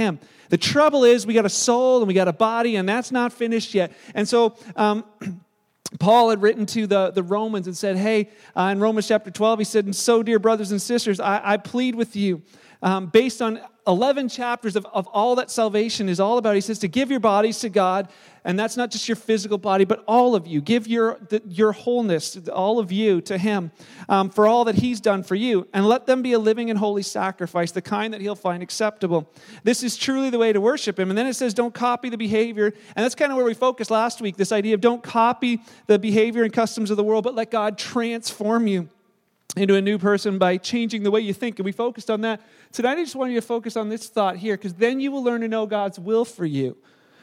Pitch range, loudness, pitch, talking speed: 200-235 Hz, -21 LUFS, 215 Hz, 245 wpm